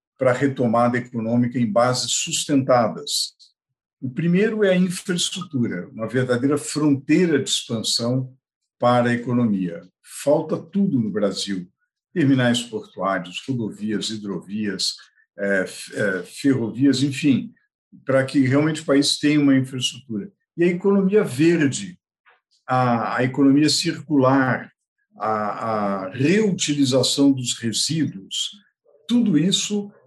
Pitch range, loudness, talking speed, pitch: 120-165 Hz, -21 LUFS, 110 wpm, 135 Hz